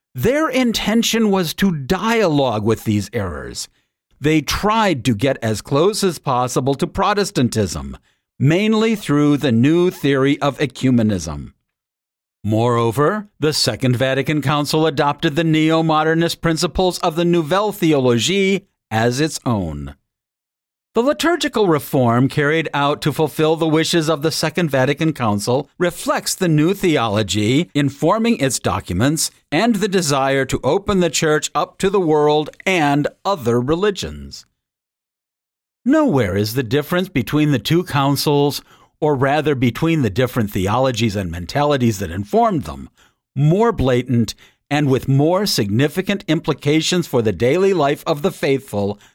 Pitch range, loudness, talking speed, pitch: 125-175 Hz, -17 LUFS, 135 wpm, 150 Hz